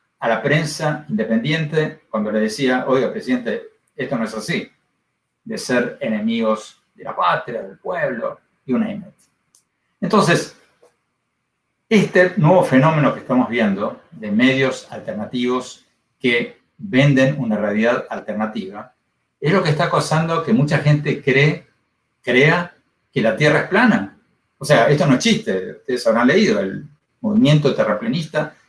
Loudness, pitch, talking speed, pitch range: -18 LUFS, 145 Hz, 140 wpm, 125-180 Hz